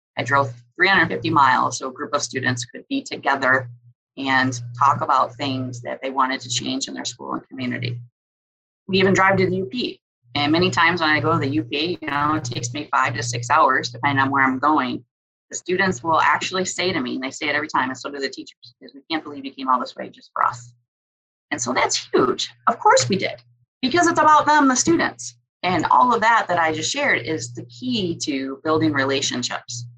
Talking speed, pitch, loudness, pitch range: 225 wpm, 140 Hz, -20 LUFS, 125-165 Hz